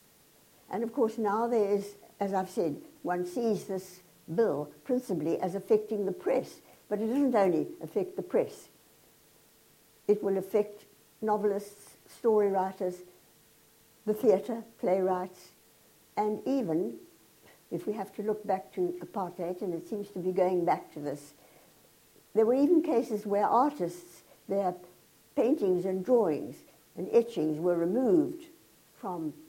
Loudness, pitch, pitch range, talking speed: -30 LUFS, 200 Hz, 180-220 Hz, 140 wpm